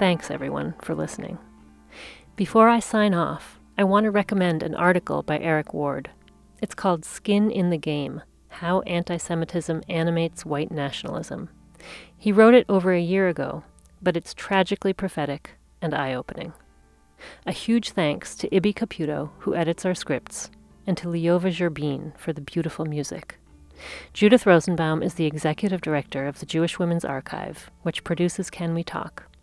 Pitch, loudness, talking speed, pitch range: 170 Hz, -24 LUFS, 155 wpm, 150-190 Hz